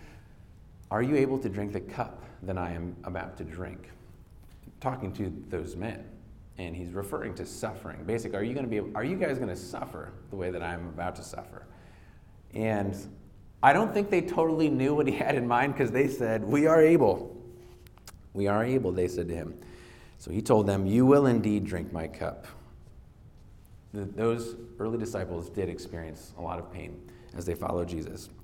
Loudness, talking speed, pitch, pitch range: -29 LUFS, 190 wpm, 100 Hz, 90-115 Hz